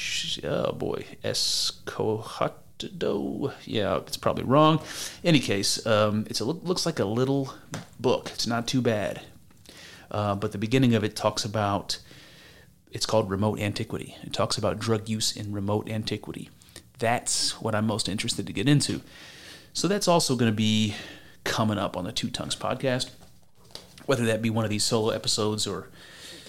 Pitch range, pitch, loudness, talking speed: 105-125 Hz, 110 Hz, -26 LUFS, 160 wpm